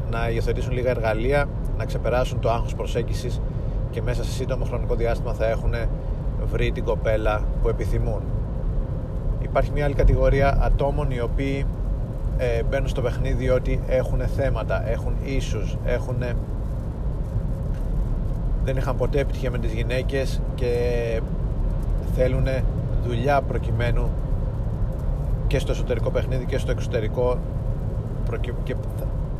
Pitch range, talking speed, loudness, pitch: 115-130 Hz, 115 wpm, -25 LUFS, 125 Hz